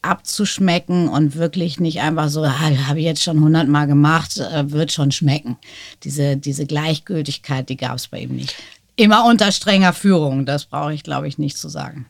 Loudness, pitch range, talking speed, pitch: -17 LUFS, 140-170 Hz, 190 wpm, 150 Hz